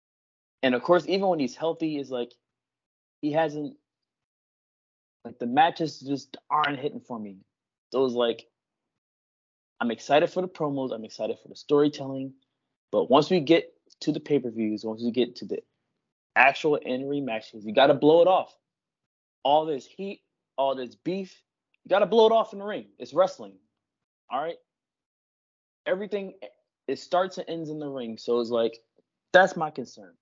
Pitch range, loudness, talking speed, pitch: 120-175 Hz, -26 LUFS, 170 wpm, 145 Hz